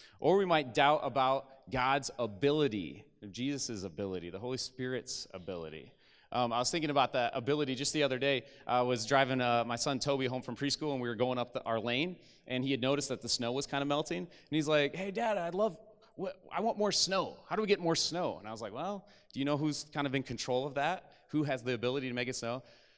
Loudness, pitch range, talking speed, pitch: -33 LUFS, 125-155 Hz, 245 wpm, 140 Hz